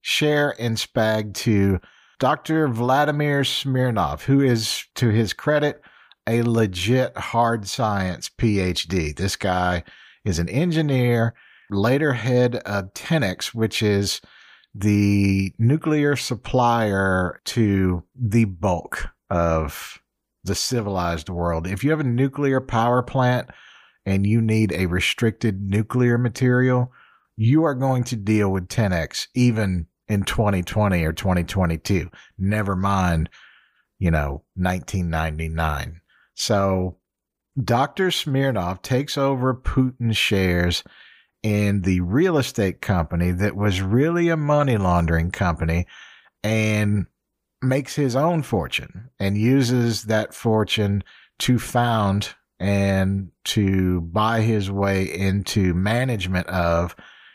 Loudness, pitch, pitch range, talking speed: -22 LUFS, 105 Hz, 95-125 Hz, 110 wpm